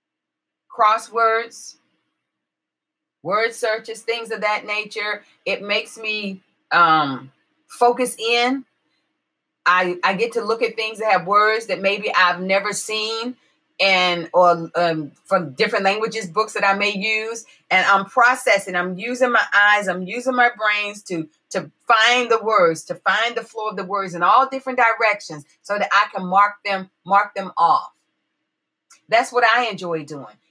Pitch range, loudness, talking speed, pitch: 185-230 Hz, -19 LUFS, 155 wpm, 210 Hz